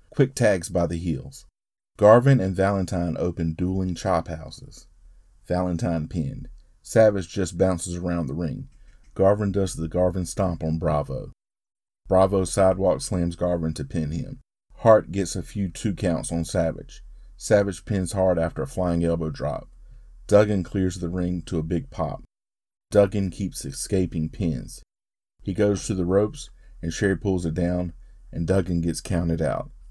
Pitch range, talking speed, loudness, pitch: 85-95 Hz, 155 wpm, -24 LUFS, 90 Hz